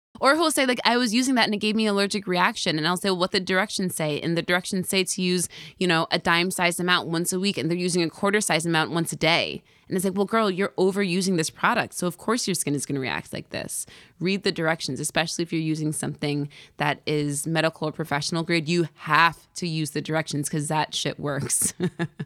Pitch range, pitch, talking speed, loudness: 155-190 Hz, 175 Hz, 245 wpm, -24 LUFS